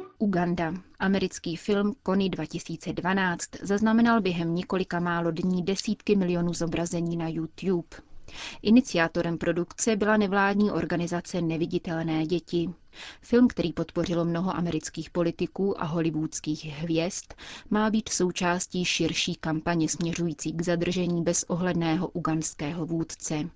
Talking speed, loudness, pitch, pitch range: 105 wpm, -27 LUFS, 175 Hz, 165-185 Hz